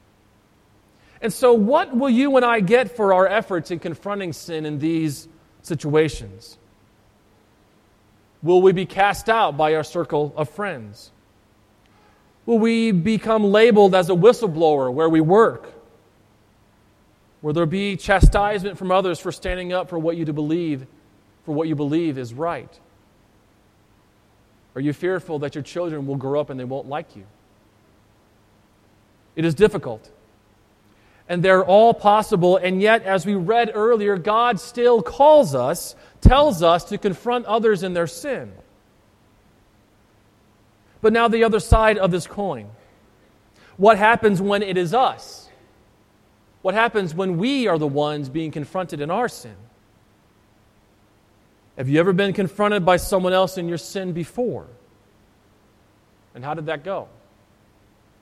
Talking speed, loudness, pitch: 140 wpm, -19 LUFS, 155 Hz